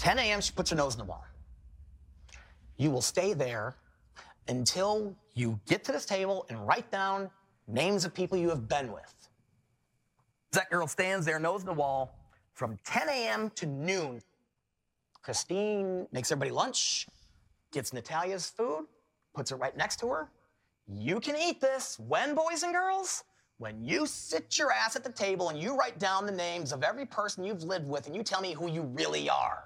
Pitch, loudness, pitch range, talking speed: 175 Hz, -32 LUFS, 125-200 Hz, 185 wpm